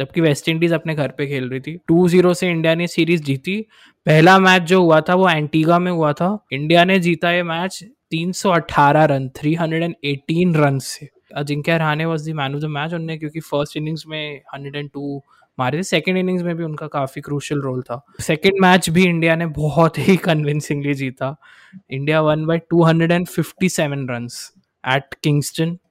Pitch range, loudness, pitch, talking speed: 145-175 Hz, -18 LUFS, 160 Hz, 140 wpm